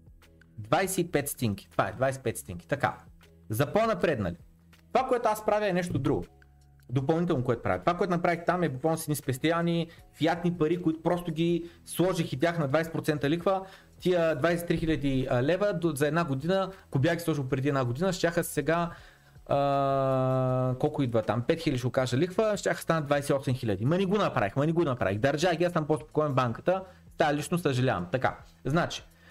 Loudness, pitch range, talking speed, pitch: -28 LUFS, 130-170 Hz, 180 wpm, 150 Hz